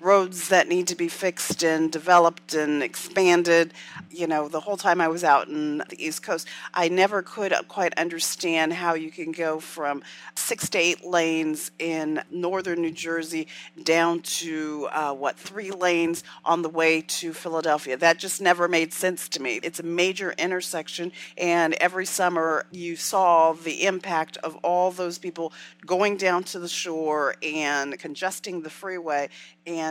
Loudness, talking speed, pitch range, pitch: -24 LUFS, 165 wpm, 160-180 Hz, 170 Hz